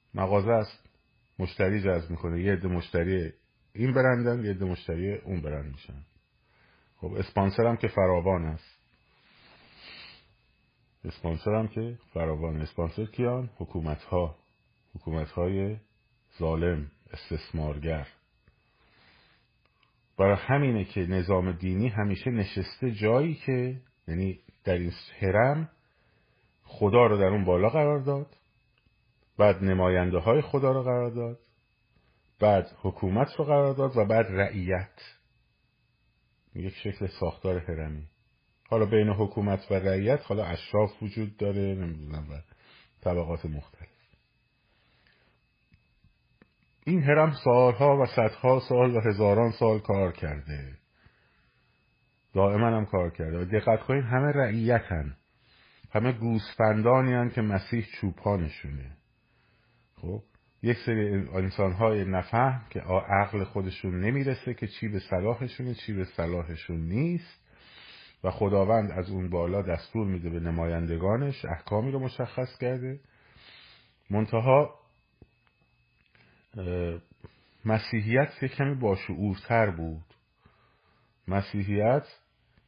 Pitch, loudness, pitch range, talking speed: 105 Hz, -28 LUFS, 90-120 Hz, 110 wpm